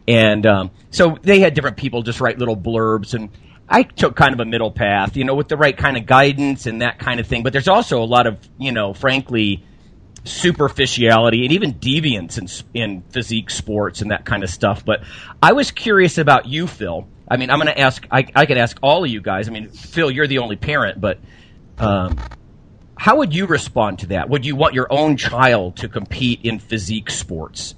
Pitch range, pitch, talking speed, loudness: 105-135 Hz, 120 Hz, 220 wpm, -17 LUFS